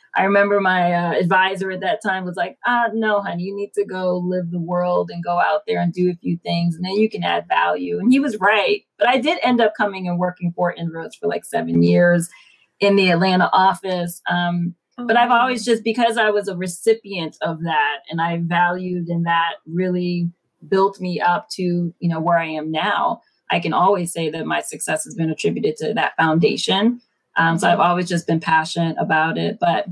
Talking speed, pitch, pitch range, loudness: 215 wpm, 180 Hz, 170-200 Hz, -19 LUFS